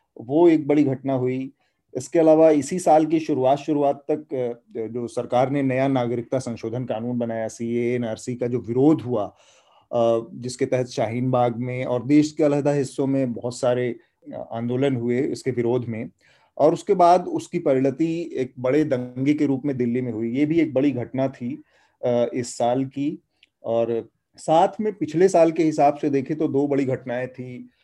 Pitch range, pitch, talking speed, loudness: 120-150 Hz, 130 Hz, 175 wpm, -22 LUFS